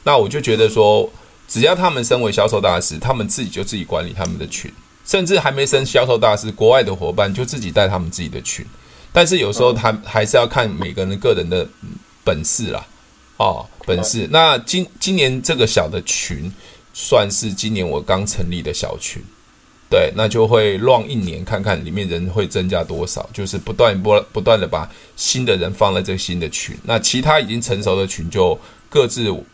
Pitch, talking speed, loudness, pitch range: 105 Hz, 295 characters per minute, -17 LUFS, 90-125 Hz